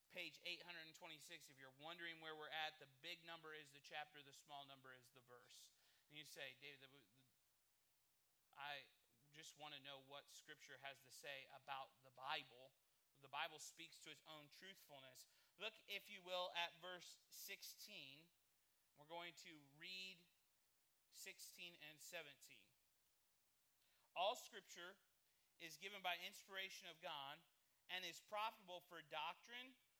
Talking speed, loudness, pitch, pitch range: 145 wpm, -55 LUFS, 155 Hz, 140-175 Hz